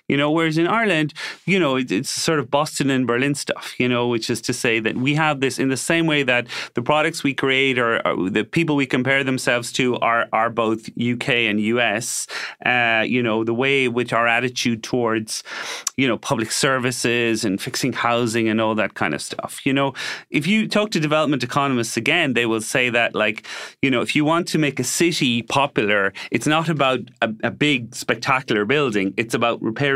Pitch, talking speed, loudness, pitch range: 130 Hz, 210 wpm, -20 LUFS, 120-145 Hz